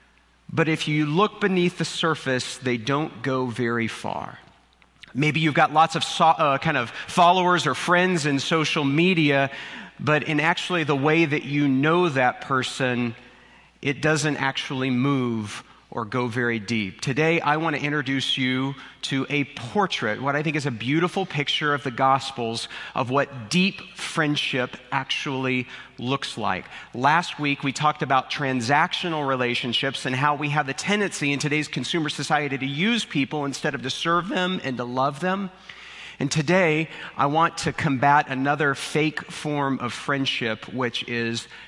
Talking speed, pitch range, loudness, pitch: 165 wpm, 130-160 Hz, -23 LUFS, 145 Hz